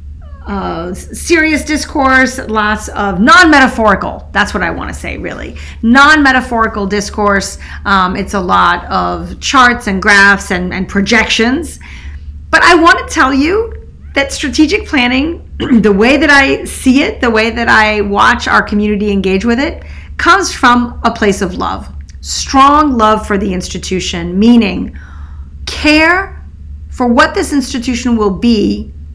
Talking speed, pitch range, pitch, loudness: 150 wpm, 190-275 Hz, 220 Hz, -10 LUFS